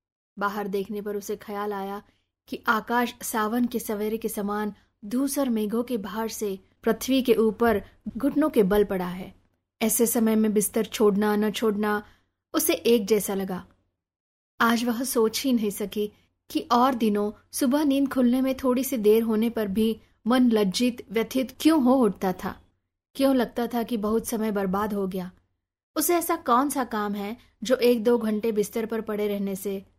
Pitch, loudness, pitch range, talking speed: 220 Hz, -25 LUFS, 205-240 Hz, 170 wpm